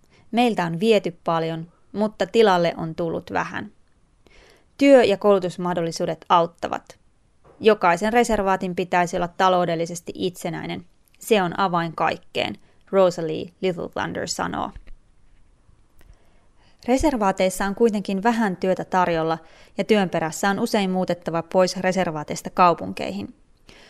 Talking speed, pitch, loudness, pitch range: 105 wpm, 185 Hz, -22 LUFS, 165-200 Hz